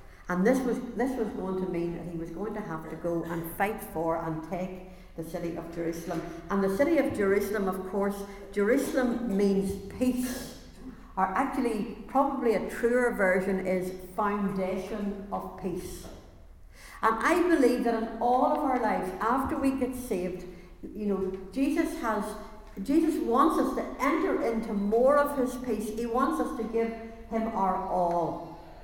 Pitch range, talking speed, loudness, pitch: 185-240 Hz, 165 wpm, -29 LUFS, 205 Hz